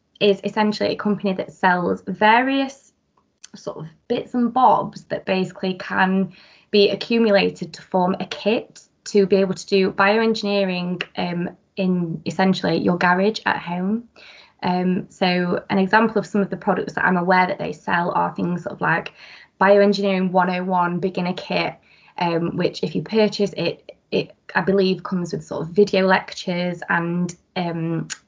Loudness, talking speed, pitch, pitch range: -20 LUFS, 160 wpm, 190 Hz, 180-205 Hz